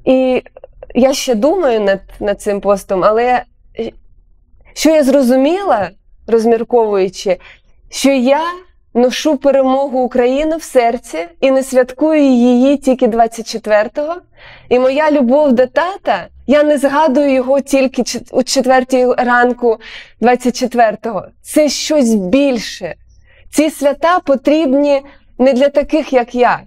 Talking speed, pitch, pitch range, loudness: 115 wpm, 260 Hz, 240-290 Hz, -13 LUFS